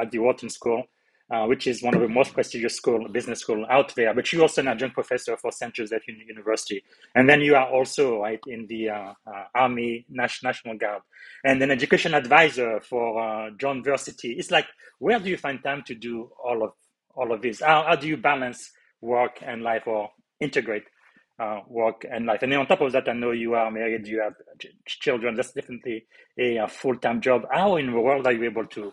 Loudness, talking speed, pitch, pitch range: -24 LUFS, 215 wpm, 120 Hz, 115-140 Hz